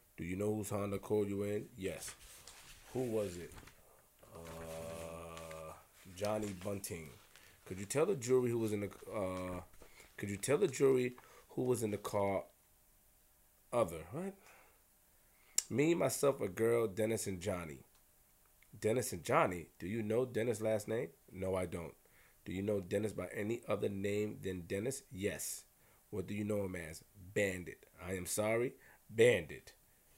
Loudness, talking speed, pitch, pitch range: -38 LUFS, 155 wpm, 100 Hz, 90-110 Hz